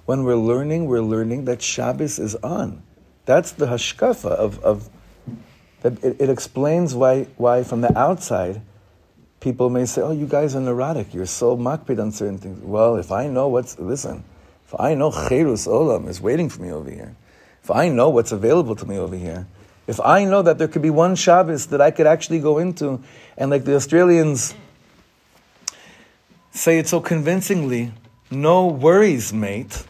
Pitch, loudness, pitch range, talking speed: 130 Hz, -19 LUFS, 115-155 Hz, 180 wpm